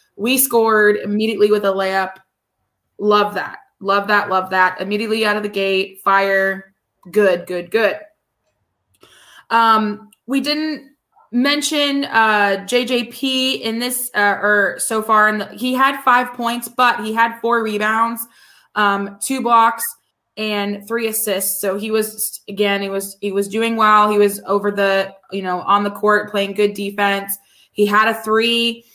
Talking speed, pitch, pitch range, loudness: 160 wpm, 210 Hz, 200-230 Hz, -17 LUFS